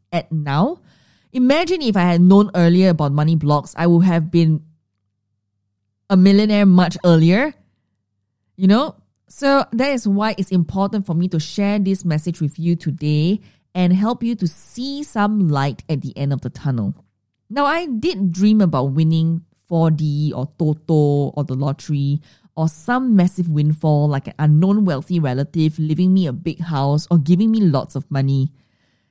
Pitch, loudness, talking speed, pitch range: 165 Hz, -18 LUFS, 165 wpm, 145-195 Hz